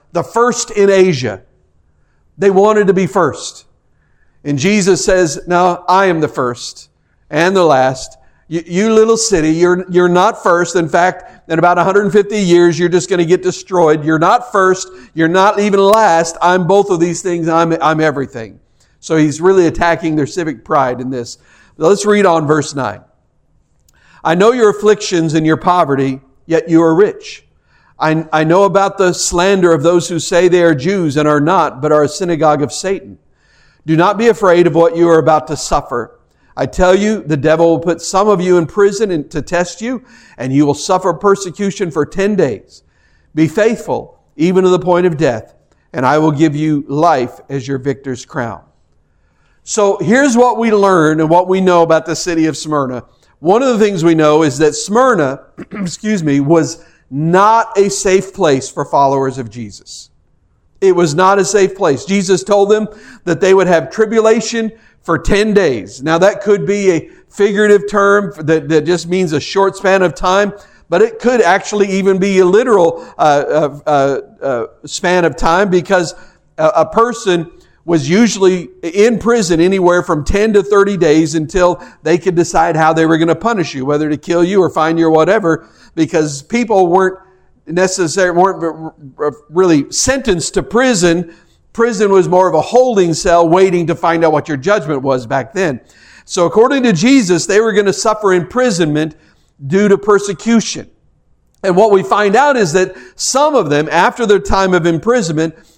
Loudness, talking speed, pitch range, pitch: -12 LUFS, 185 wpm, 155-200 Hz, 175 Hz